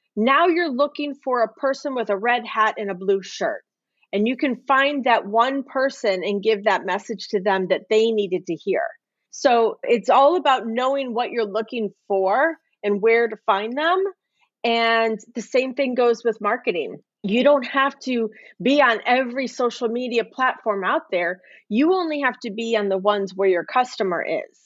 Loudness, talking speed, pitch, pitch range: -21 LUFS, 185 wpm, 235 Hz, 210-265 Hz